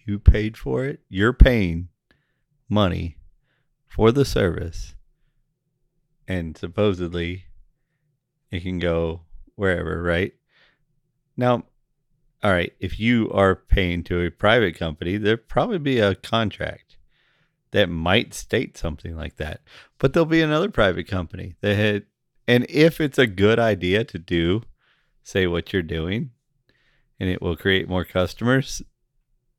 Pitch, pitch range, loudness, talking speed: 100 Hz, 90-130 Hz, -22 LUFS, 130 wpm